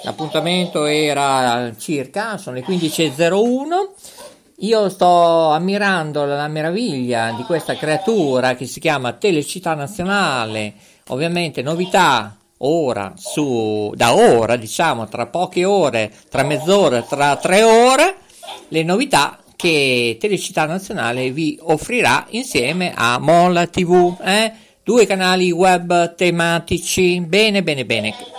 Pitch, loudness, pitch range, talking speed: 165 Hz, -16 LUFS, 140-185 Hz, 110 wpm